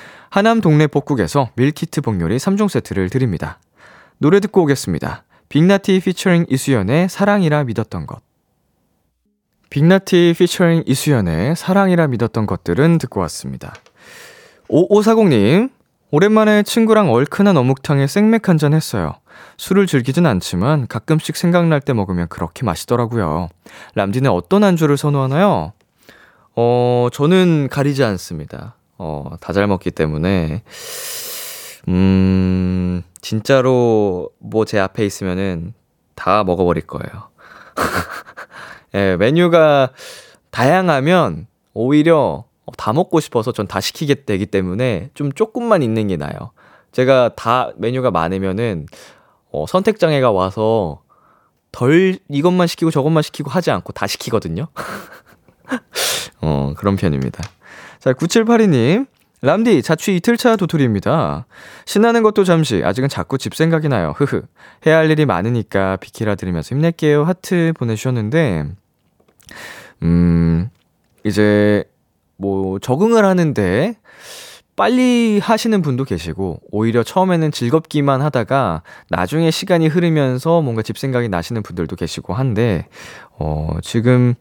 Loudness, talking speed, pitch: -16 LUFS, 275 characters per minute, 135 Hz